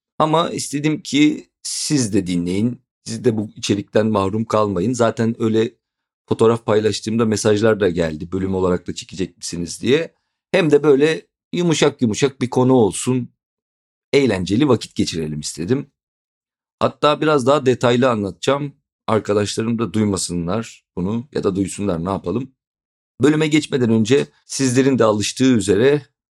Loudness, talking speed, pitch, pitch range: -18 LUFS, 130 wpm, 115 Hz, 100-135 Hz